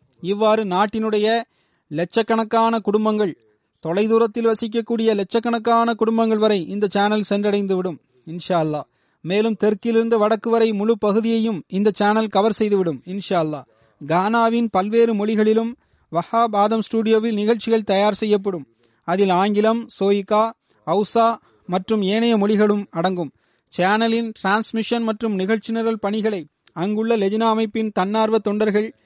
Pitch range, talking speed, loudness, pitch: 190-225 Hz, 110 wpm, -20 LUFS, 215 Hz